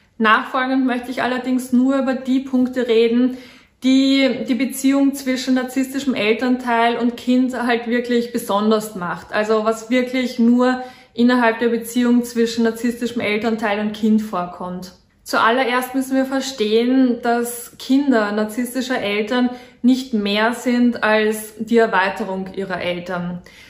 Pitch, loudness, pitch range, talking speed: 240 Hz, -18 LUFS, 220-255 Hz, 125 wpm